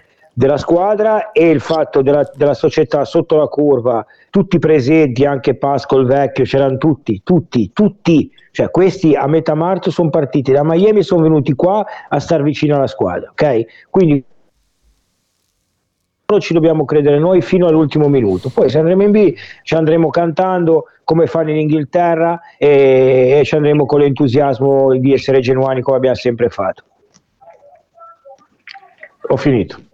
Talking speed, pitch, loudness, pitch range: 150 wpm, 155 Hz, -13 LUFS, 135-175 Hz